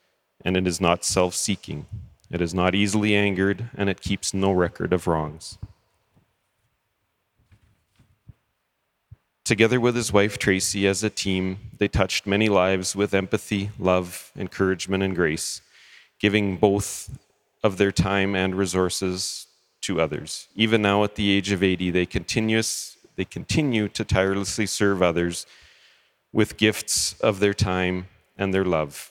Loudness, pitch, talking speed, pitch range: -23 LUFS, 100 Hz, 135 wpm, 95-105 Hz